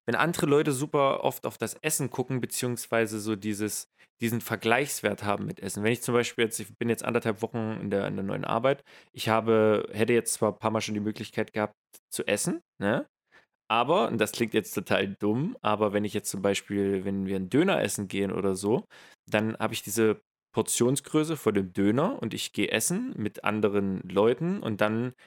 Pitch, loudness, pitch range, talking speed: 110 Hz, -28 LUFS, 105-120 Hz, 205 wpm